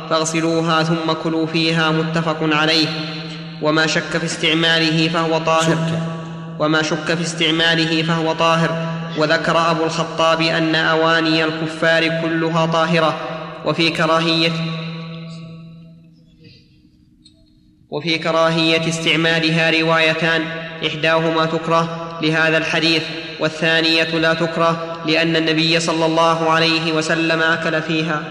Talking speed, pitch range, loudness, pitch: 100 wpm, 160-165 Hz, -17 LUFS, 165 Hz